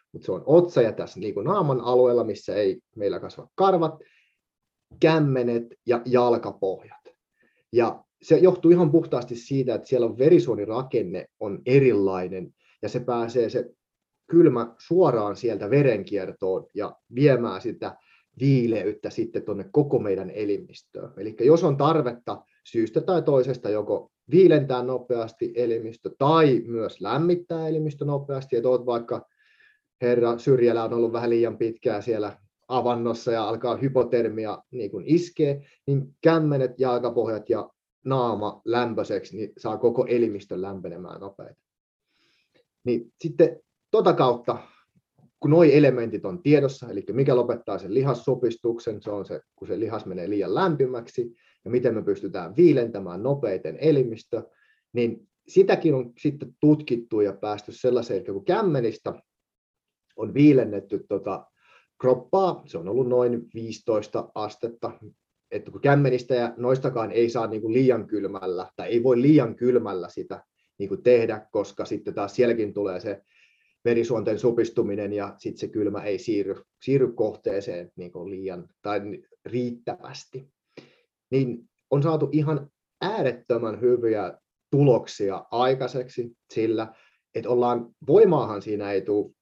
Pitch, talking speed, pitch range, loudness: 125 Hz, 130 wpm, 115-155 Hz, -24 LUFS